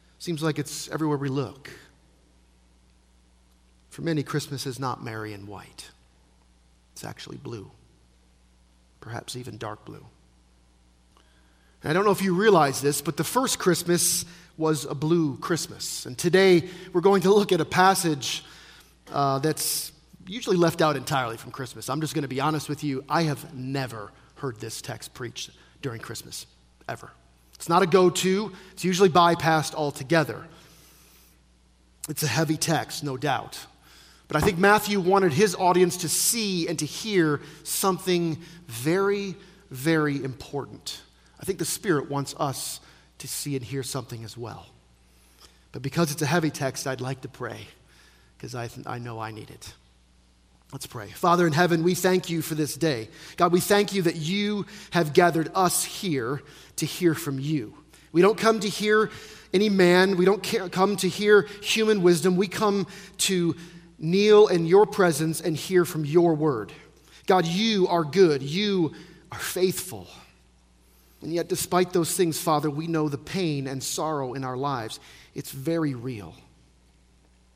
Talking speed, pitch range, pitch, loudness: 160 wpm, 115-180 Hz, 155 Hz, -24 LUFS